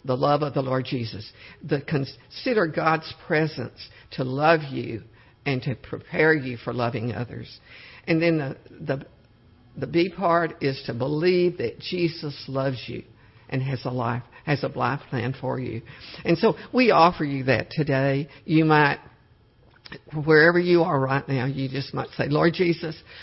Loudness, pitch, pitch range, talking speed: -24 LUFS, 135 Hz, 120-155 Hz, 165 wpm